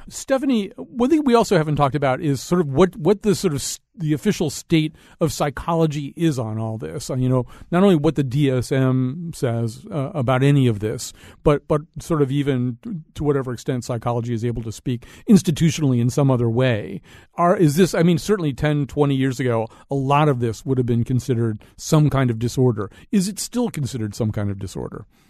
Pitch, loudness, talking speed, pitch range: 140 Hz, -21 LUFS, 210 wpm, 125-165 Hz